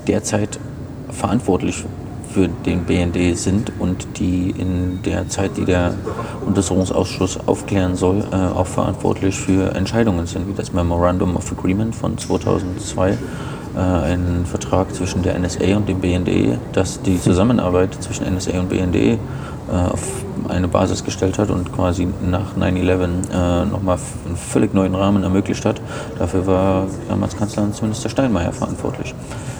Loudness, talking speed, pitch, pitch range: -19 LUFS, 145 wpm, 95 Hz, 90-105 Hz